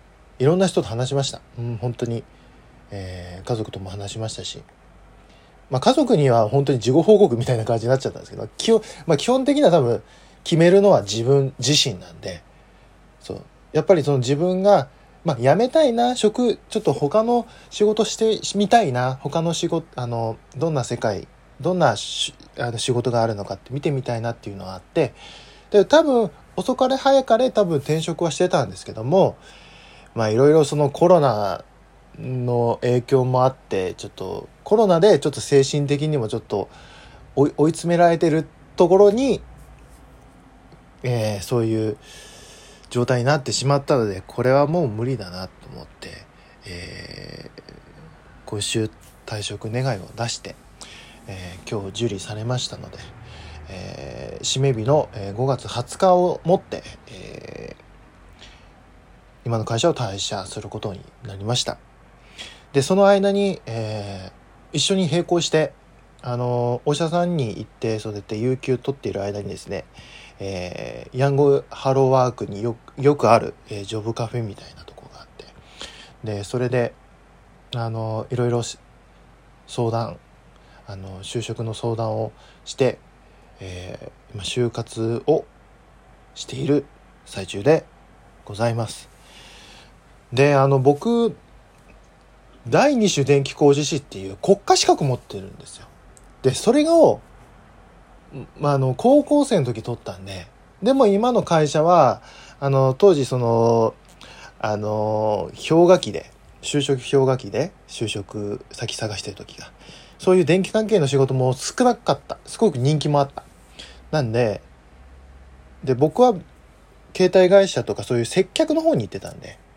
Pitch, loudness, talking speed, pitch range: 130 Hz, -20 LUFS, 285 characters per minute, 110-165 Hz